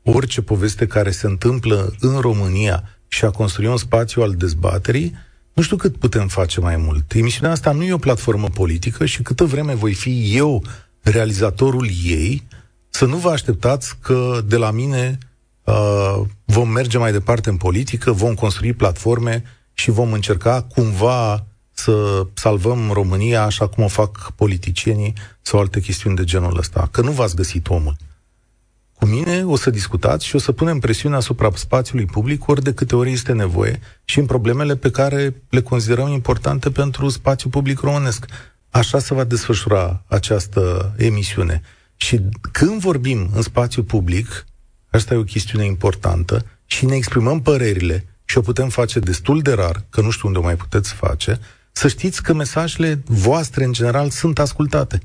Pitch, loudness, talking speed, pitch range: 115 Hz, -18 LUFS, 165 wpm, 100-130 Hz